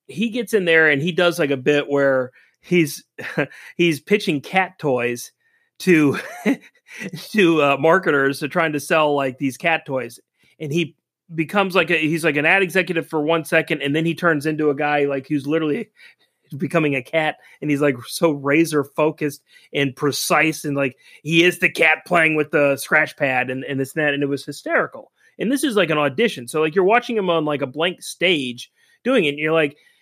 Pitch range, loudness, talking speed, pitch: 140-170 Hz, -19 LUFS, 205 wpm, 155 Hz